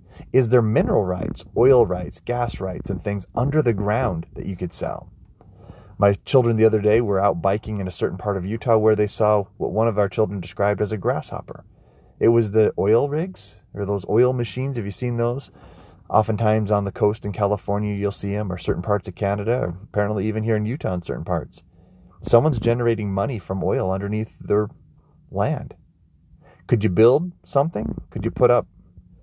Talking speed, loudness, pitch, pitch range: 195 wpm, -22 LUFS, 105 Hz, 100-115 Hz